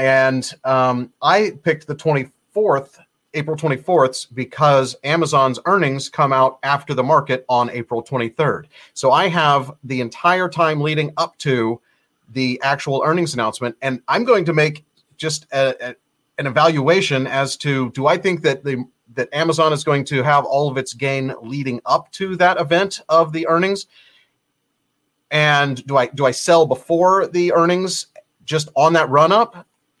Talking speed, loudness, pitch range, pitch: 160 wpm, -18 LUFS, 130-165 Hz, 145 Hz